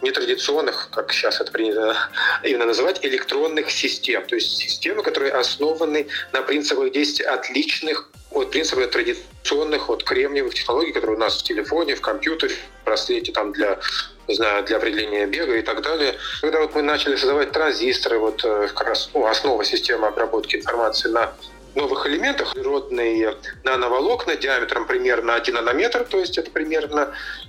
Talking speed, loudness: 150 wpm, -21 LUFS